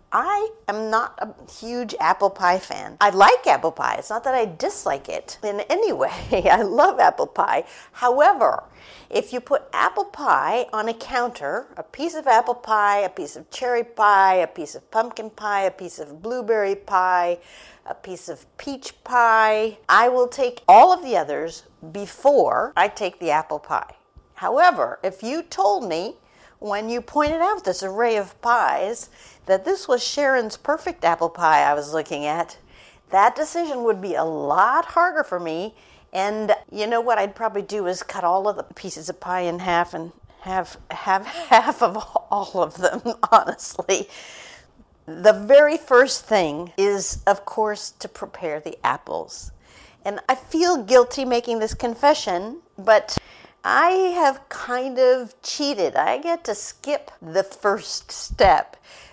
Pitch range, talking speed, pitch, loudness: 190-260 Hz, 165 wpm, 220 Hz, -20 LUFS